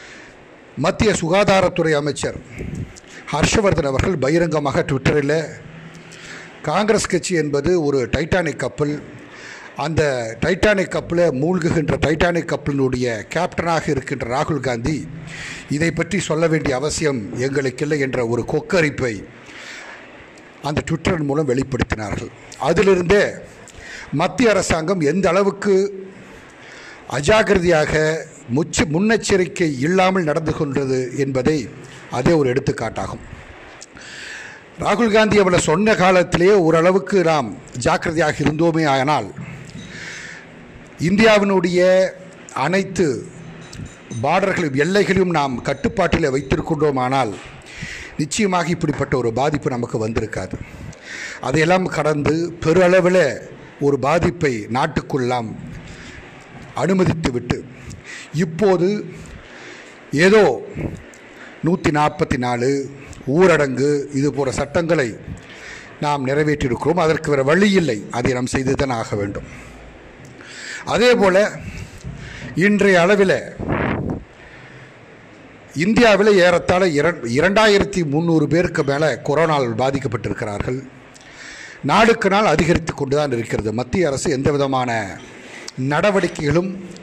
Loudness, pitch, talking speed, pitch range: -18 LUFS, 155 Hz, 85 wpm, 140-185 Hz